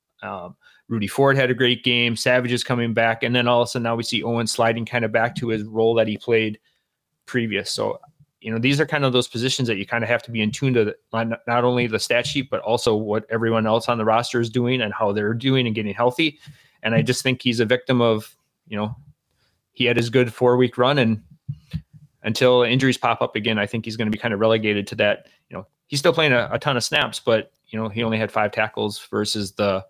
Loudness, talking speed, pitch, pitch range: -21 LUFS, 255 wpm, 120 Hz, 110-125 Hz